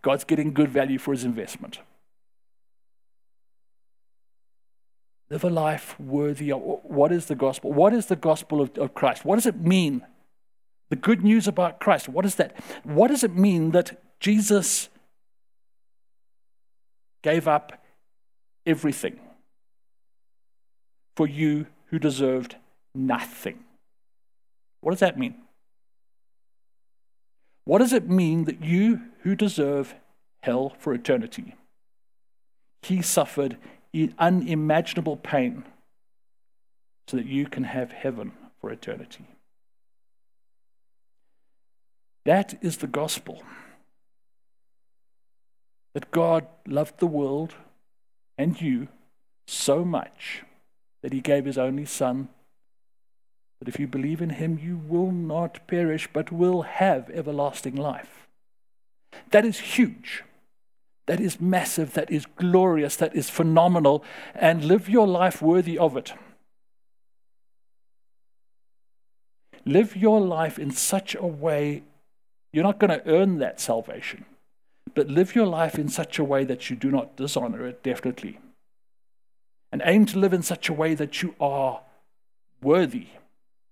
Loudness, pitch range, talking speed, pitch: -24 LUFS, 145-185 Hz, 120 wpm, 160 Hz